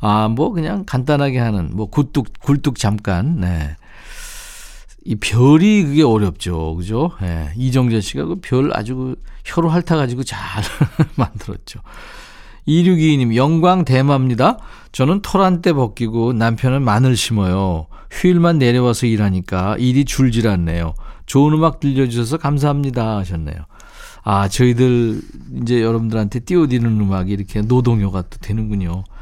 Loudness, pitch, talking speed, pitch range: -16 LUFS, 120 Hz, 300 characters per minute, 105-145 Hz